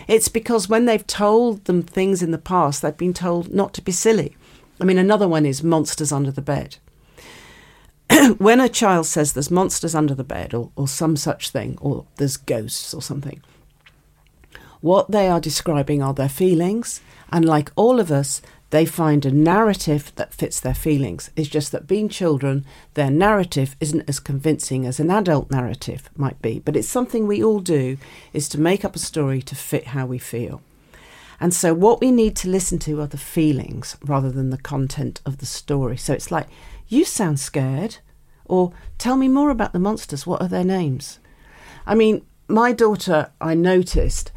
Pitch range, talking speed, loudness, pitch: 140-190 Hz, 190 wpm, -20 LUFS, 155 Hz